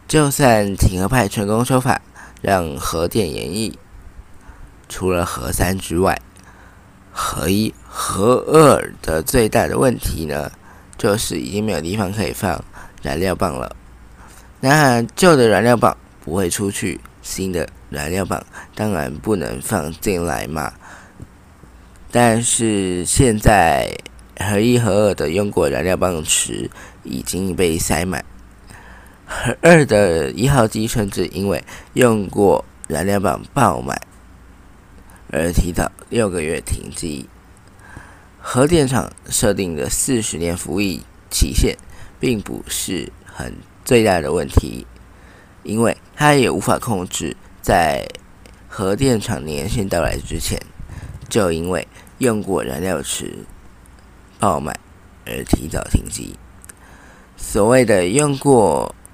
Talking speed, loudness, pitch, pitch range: 175 characters per minute, -18 LUFS, 95 Hz, 90-110 Hz